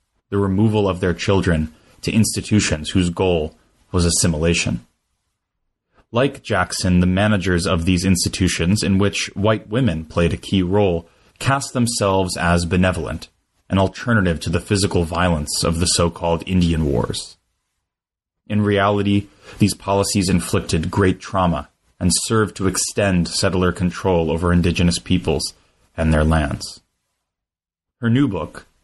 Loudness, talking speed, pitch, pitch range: -19 LUFS, 135 wpm, 90 Hz, 85-100 Hz